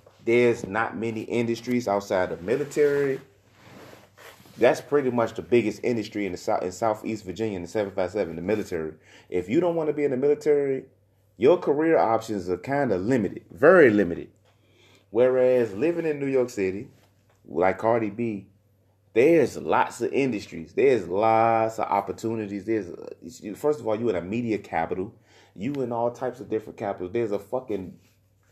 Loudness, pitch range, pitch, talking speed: -25 LUFS, 100-125 Hz, 110 Hz, 175 wpm